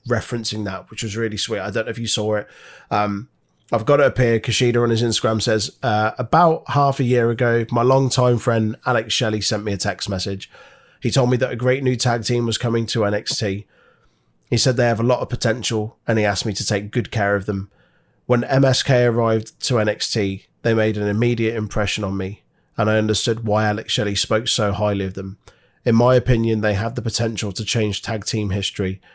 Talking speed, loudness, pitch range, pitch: 215 wpm, -20 LUFS, 105-120 Hz, 110 Hz